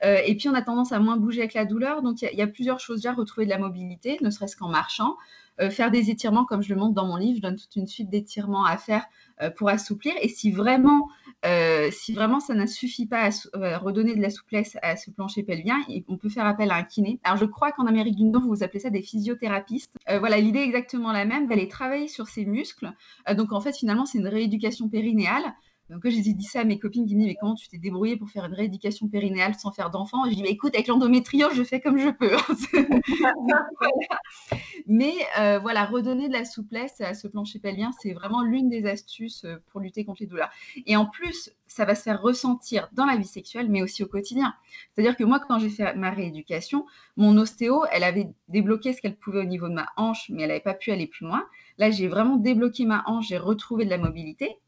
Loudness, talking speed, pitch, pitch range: -25 LUFS, 245 wpm, 220 Hz, 200-245 Hz